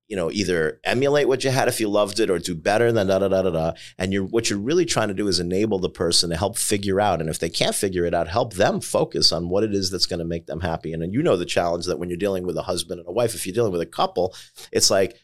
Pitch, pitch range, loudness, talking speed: 100 Hz, 90-115 Hz, -22 LUFS, 315 wpm